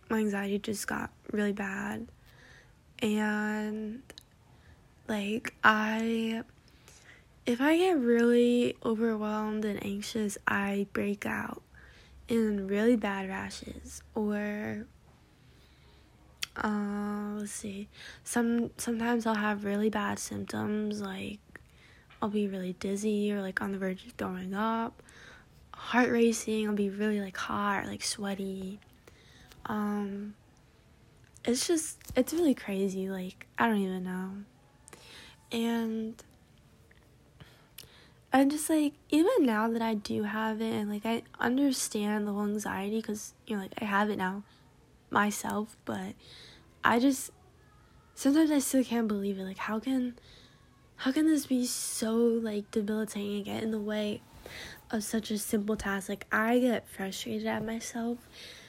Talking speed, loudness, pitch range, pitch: 135 wpm, -31 LUFS, 200-230 Hz, 215 Hz